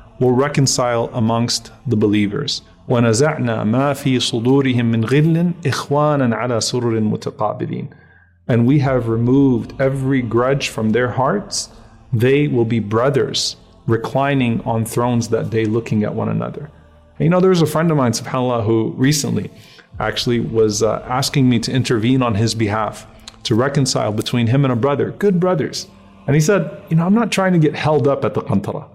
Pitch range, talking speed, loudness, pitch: 115-140 Hz, 170 wpm, -17 LUFS, 125 Hz